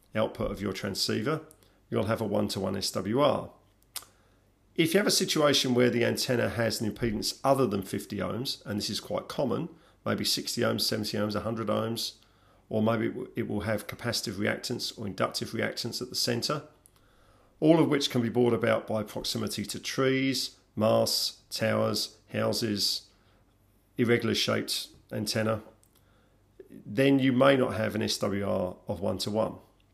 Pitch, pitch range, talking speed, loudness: 110 Hz, 105-120 Hz, 160 wpm, -29 LUFS